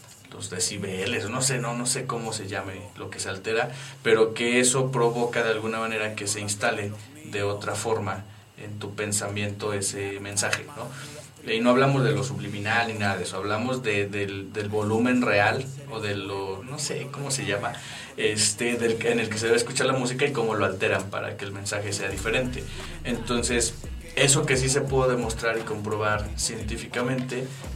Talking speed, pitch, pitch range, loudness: 185 wpm, 110 Hz, 100-130 Hz, -26 LUFS